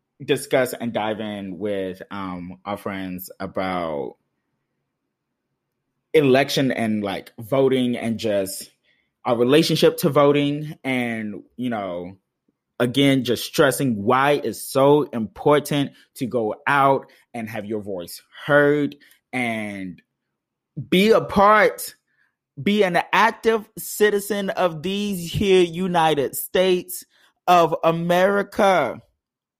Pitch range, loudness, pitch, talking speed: 110-175 Hz, -20 LUFS, 140 Hz, 105 wpm